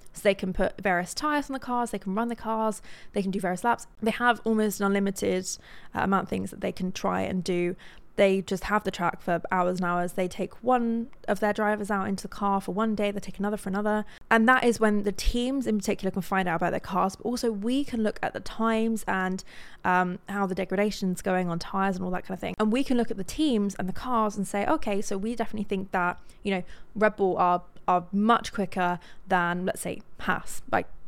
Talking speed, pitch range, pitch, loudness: 245 wpm, 185-225 Hz, 200 Hz, -27 LUFS